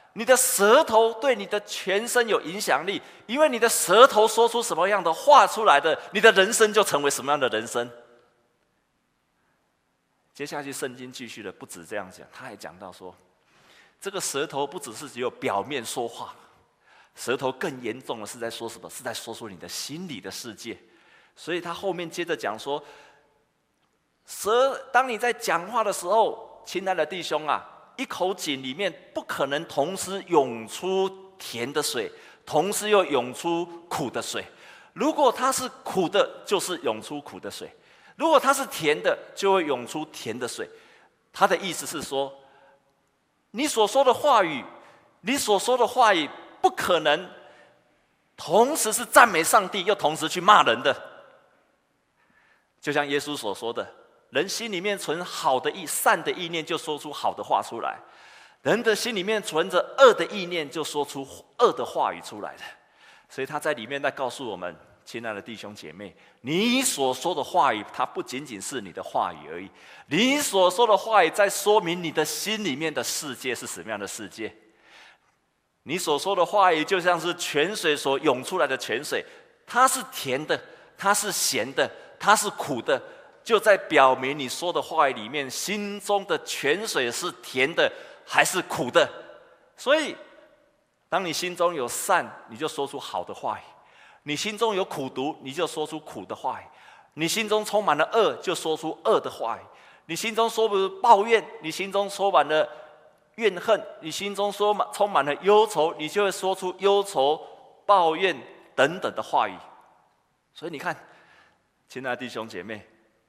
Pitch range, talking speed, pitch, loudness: 145-225 Hz, 245 characters per minute, 185 Hz, -24 LUFS